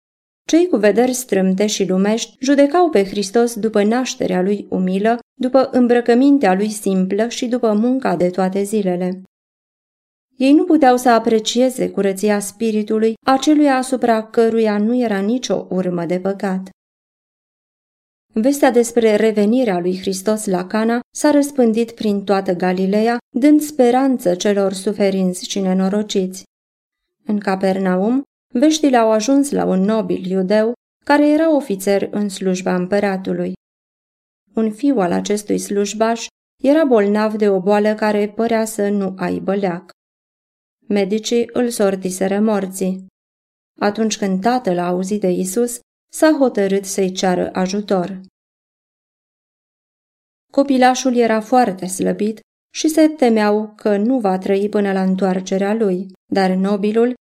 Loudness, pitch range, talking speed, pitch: -17 LUFS, 195-245 Hz, 125 wpm, 215 Hz